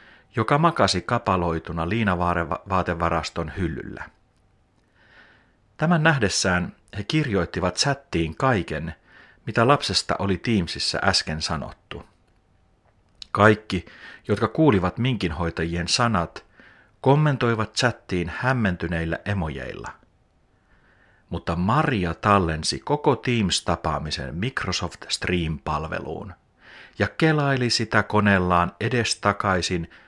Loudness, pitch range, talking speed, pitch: -23 LUFS, 85-110 Hz, 75 wpm, 95 Hz